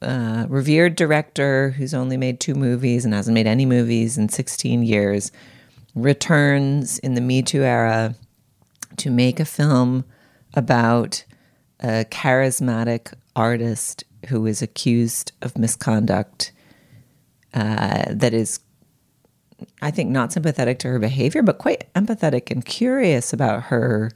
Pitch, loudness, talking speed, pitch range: 125 Hz, -20 LUFS, 130 wpm, 115-140 Hz